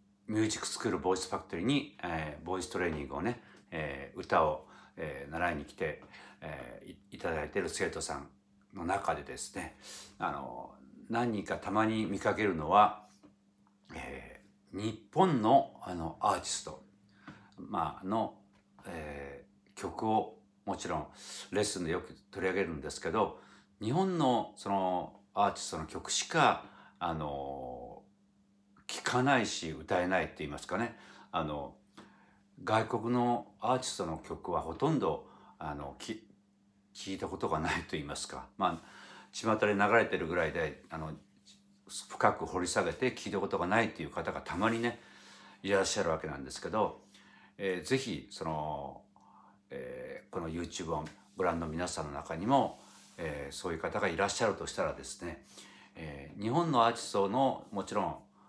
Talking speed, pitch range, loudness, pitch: 295 characters per minute, 80-110 Hz, -34 LUFS, 100 Hz